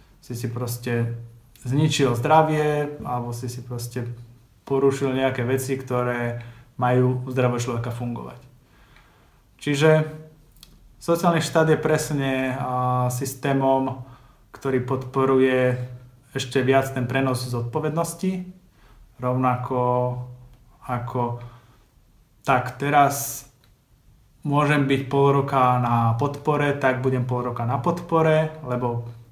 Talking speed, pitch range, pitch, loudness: 100 wpm, 125-140 Hz, 130 Hz, -23 LUFS